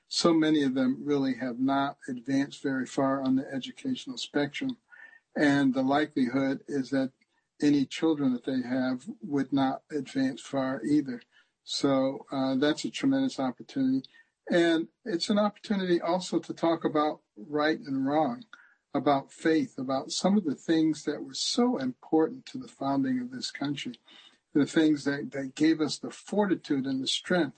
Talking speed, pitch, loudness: 160 wpm, 155 Hz, -29 LUFS